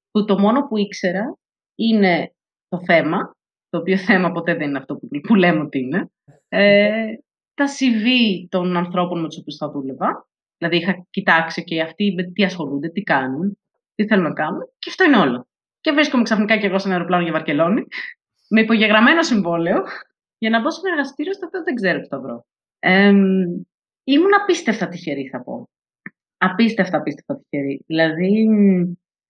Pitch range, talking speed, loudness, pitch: 170-225 Hz, 170 wpm, -18 LUFS, 195 Hz